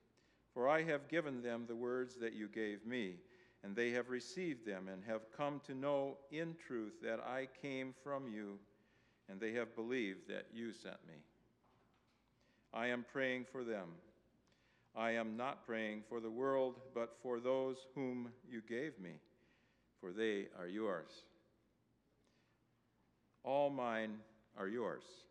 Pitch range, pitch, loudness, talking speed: 110-130 Hz, 120 Hz, -43 LUFS, 150 wpm